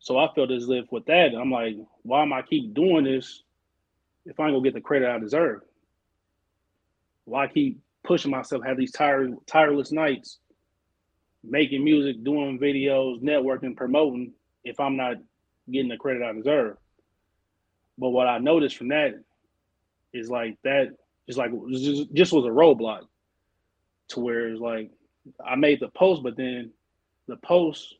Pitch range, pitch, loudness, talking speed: 95-140 Hz, 125 Hz, -24 LUFS, 160 wpm